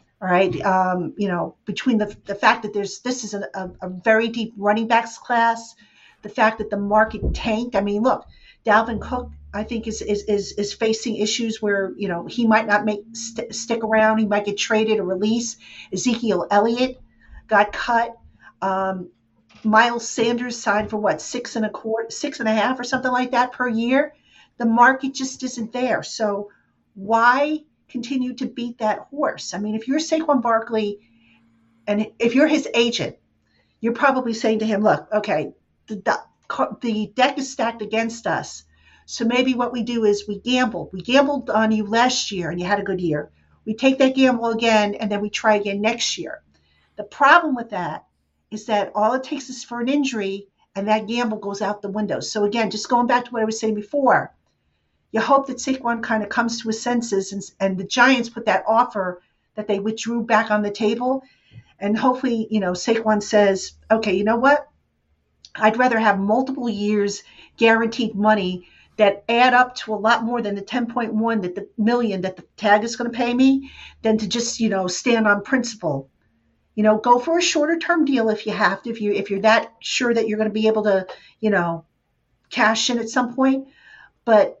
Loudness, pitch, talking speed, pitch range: -21 LUFS, 220 Hz, 205 wpm, 205-240 Hz